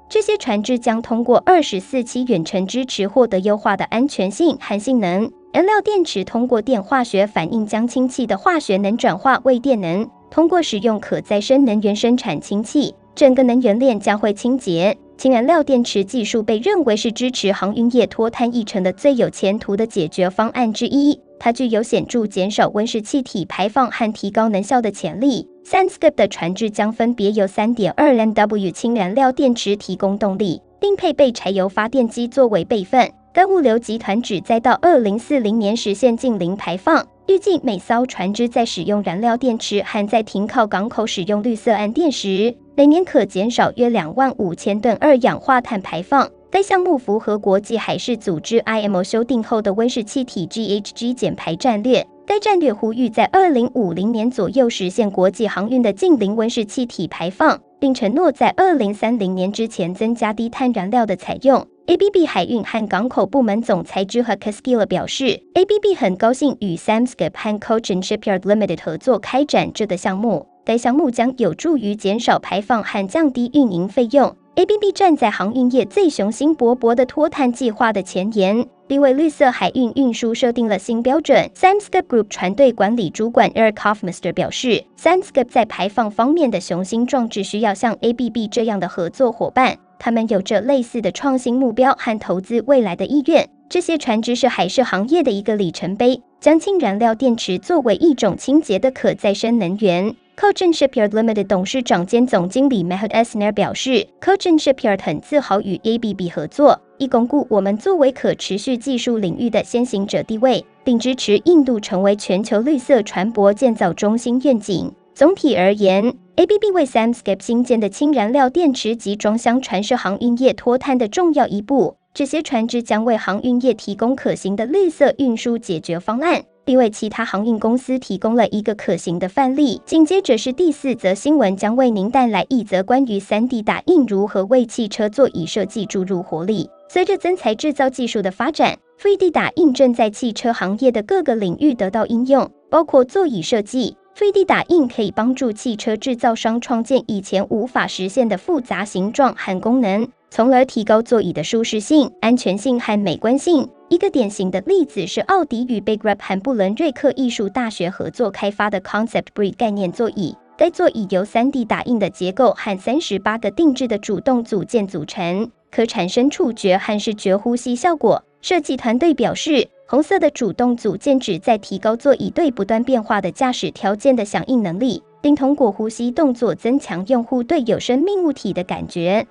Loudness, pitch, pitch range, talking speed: -17 LUFS, 230 Hz, 205-265 Hz, 315 characters per minute